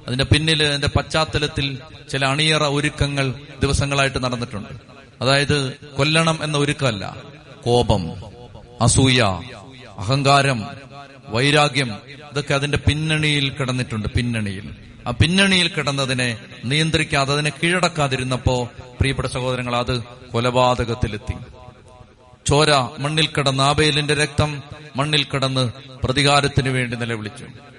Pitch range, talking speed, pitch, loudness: 120-145 Hz, 90 wpm, 135 Hz, -19 LUFS